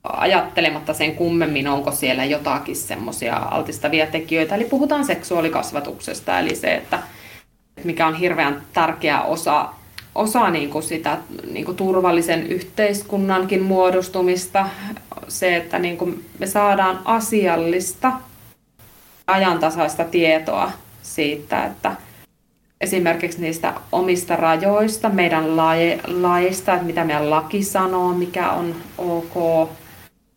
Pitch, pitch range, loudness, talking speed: 175 Hz, 160-185 Hz, -20 LUFS, 100 wpm